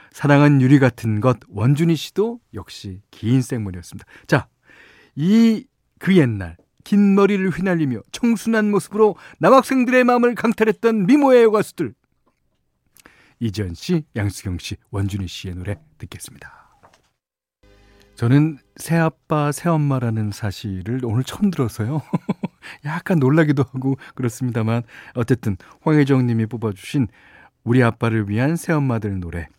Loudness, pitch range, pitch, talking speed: -19 LUFS, 110-180 Hz, 135 Hz, 290 characters per minute